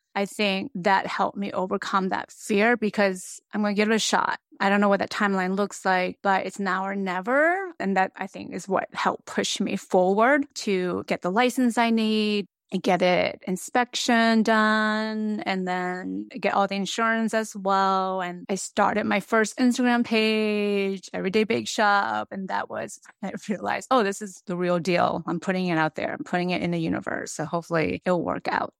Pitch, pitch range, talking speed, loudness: 200 Hz, 185-220 Hz, 200 wpm, -24 LUFS